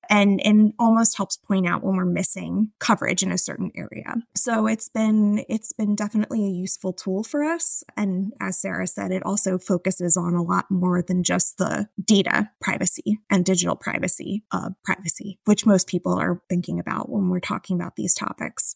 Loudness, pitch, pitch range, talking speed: -18 LUFS, 195 Hz, 185-215 Hz, 185 wpm